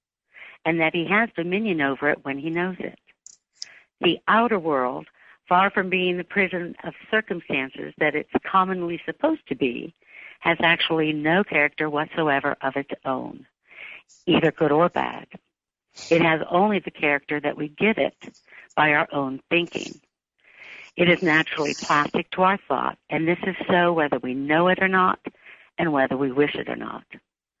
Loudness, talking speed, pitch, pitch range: -22 LUFS, 165 wpm, 165 Hz, 145-180 Hz